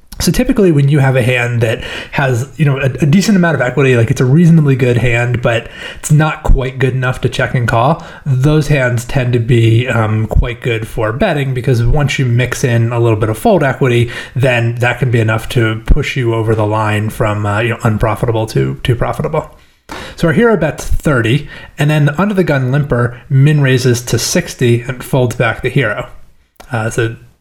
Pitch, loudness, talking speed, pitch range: 125 Hz, -13 LUFS, 210 wpm, 115-145 Hz